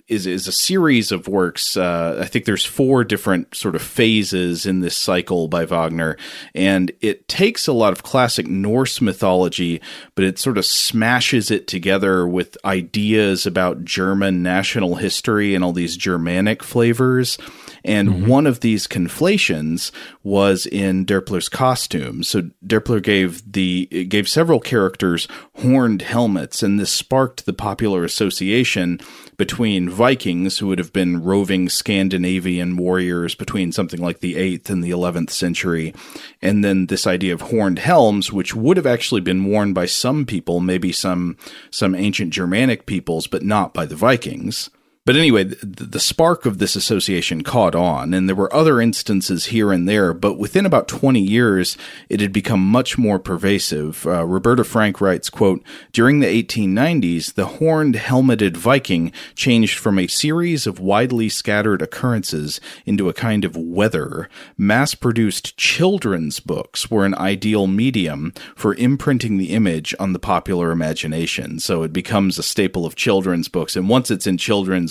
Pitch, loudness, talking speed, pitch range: 95 Hz, -18 LUFS, 160 wpm, 90-115 Hz